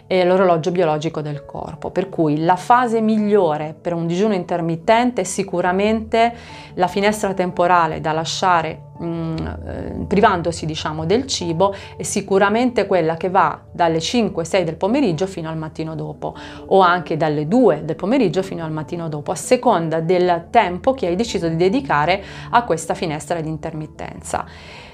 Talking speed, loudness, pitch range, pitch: 155 wpm, -19 LUFS, 160-195 Hz, 175 Hz